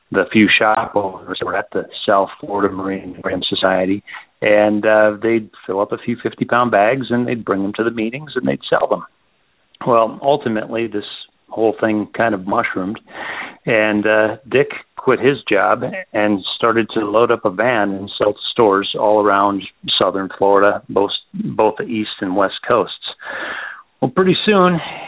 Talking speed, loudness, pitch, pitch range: 170 wpm, -17 LUFS, 110 Hz, 100-115 Hz